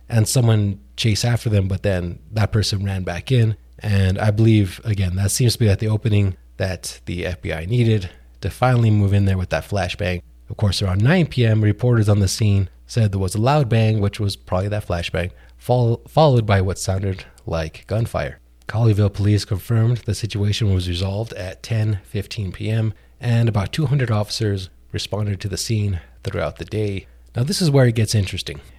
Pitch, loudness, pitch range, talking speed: 105 Hz, -20 LUFS, 95-110 Hz, 190 wpm